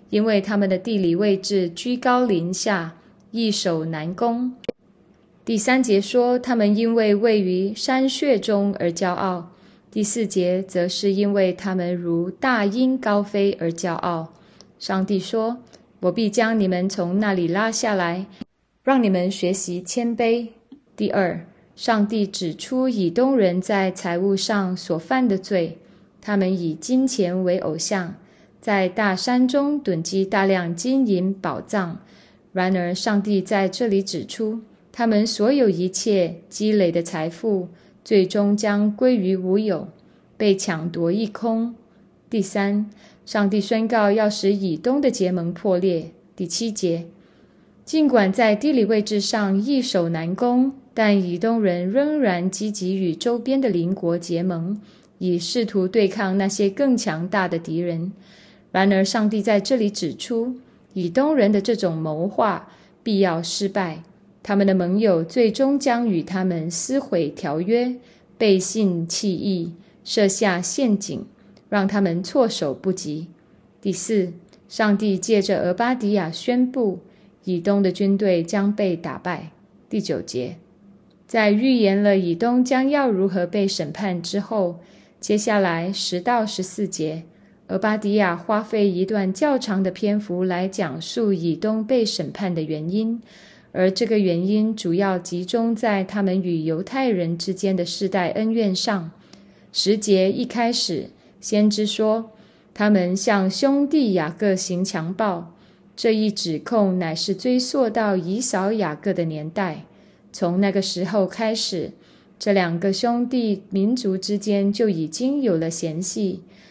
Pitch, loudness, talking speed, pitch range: 200 Hz, -21 LUFS, 205 characters per minute, 180-220 Hz